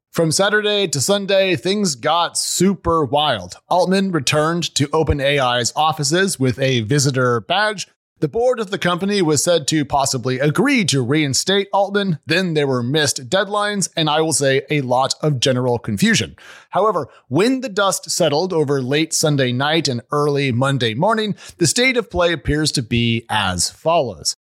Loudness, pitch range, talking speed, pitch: -17 LUFS, 135-190 Hz, 160 wpm, 155 Hz